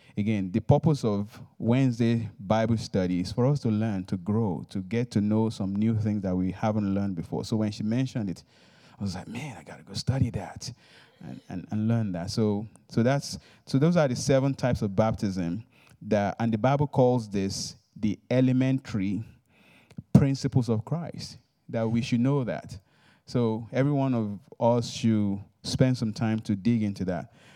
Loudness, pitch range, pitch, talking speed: -27 LUFS, 105-130 Hz, 115 Hz, 185 wpm